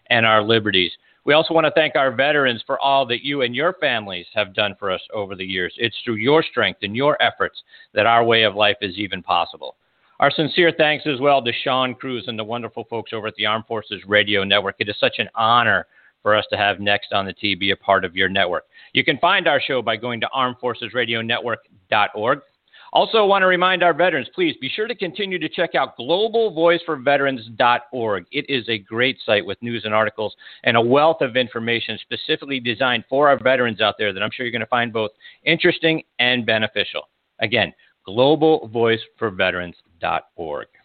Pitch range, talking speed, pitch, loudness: 110-150 Hz, 200 wpm, 120 Hz, -19 LUFS